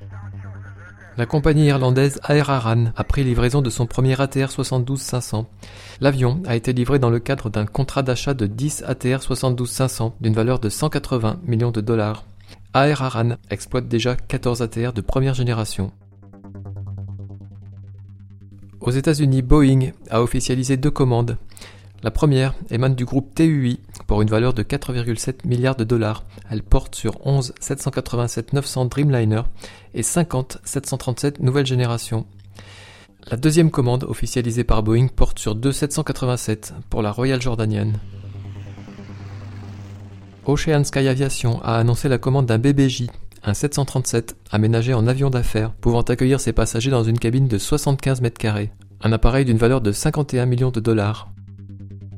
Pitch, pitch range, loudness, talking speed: 120 Hz, 105-130 Hz, -20 LUFS, 145 wpm